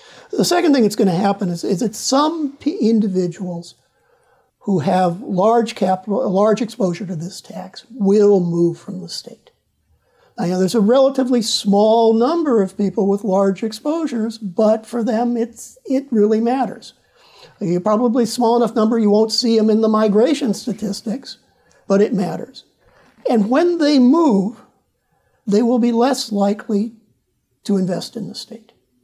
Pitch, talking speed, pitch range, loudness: 220 Hz, 160 wpm, 200-245 Hz, -17 LUFS